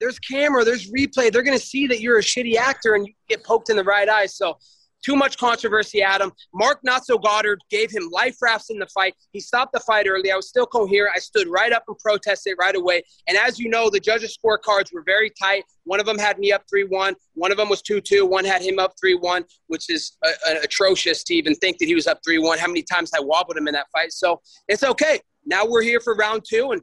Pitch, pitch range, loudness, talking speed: 210 Hz, 190-245 Hz, -20 LUFS, 250 wpm